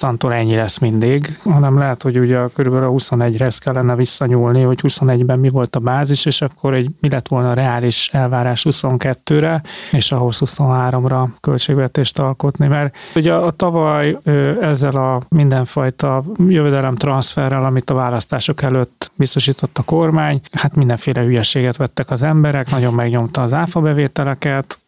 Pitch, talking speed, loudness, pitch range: 135 Hz, 150 wpm, -15 LUFS, 125-145 Hz